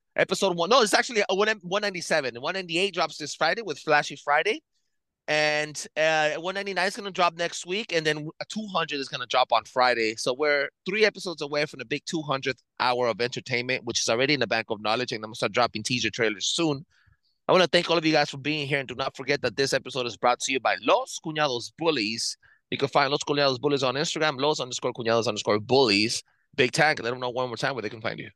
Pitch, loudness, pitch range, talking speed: 145 Hz, -25 LUFS, 125-165 Hz, 235 wpm